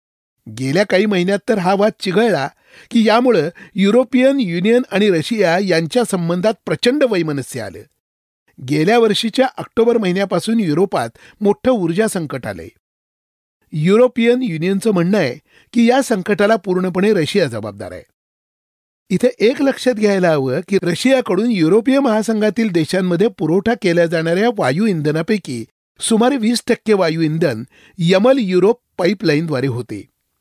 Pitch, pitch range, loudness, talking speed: 195 Hz, 165-230 Hz, -16 LUFS, 120 wpm